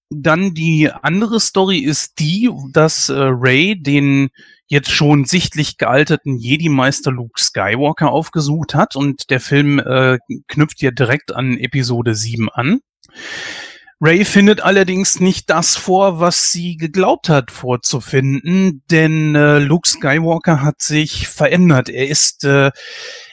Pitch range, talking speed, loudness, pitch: 135-175 Hz, 130 wpm, -14 LUFS, 150 Hz